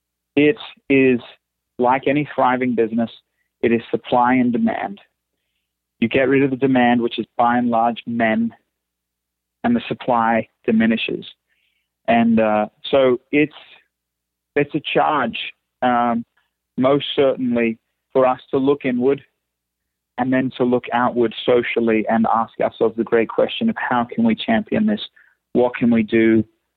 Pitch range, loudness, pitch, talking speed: 110-130 Hz, -19 LUFS, 120 Hz, 145 wpm